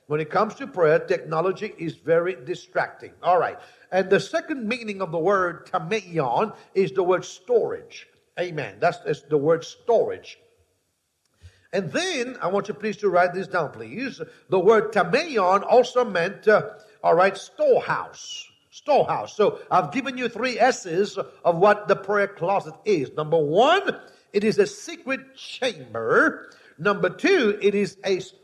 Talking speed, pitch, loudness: 155 wpm, 210 Hz, -23 LUFS